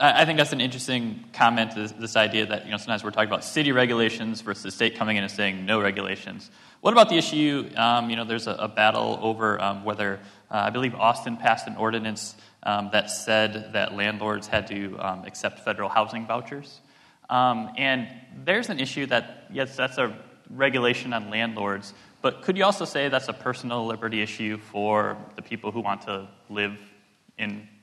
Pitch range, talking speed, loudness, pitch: 105-125 Hz, 195 wpm, -25 LUFS, 110 Hz